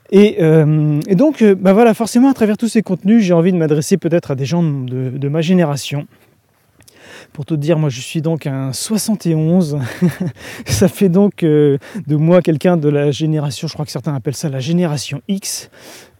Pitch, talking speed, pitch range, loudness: 165 Hz, 195 wpm, 145-190 Hz, -15 LUFS